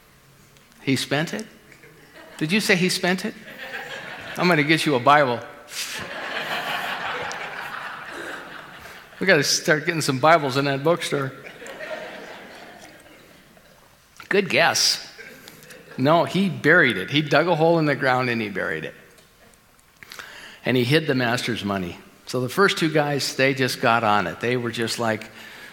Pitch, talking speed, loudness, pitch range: 140 Hz, 140 wpm, -21 LUFS, 125-170 Hz